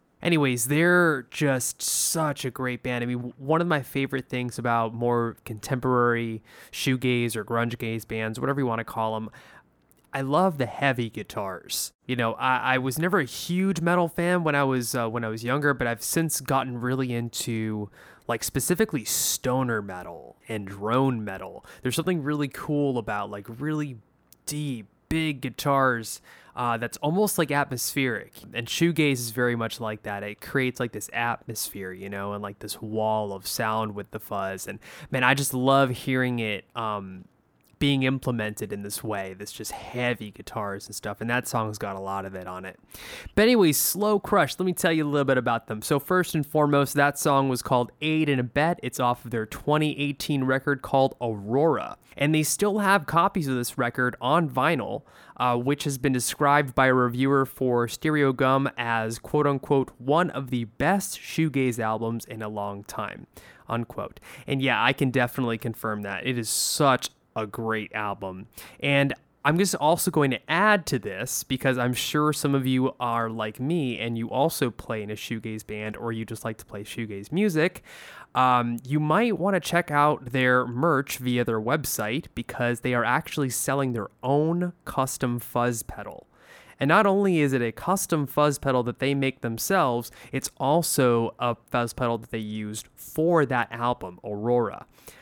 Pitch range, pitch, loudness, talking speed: 115-145 Hz, 125 Hz, -25 LUFS, 185 wpm